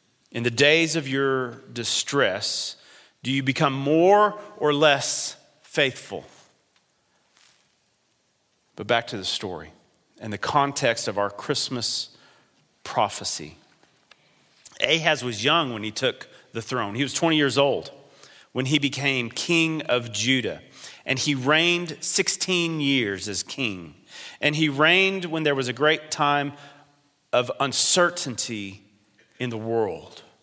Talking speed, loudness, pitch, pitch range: 130 wpm, -23 LUFS, 140 Hz, 120-155 Hz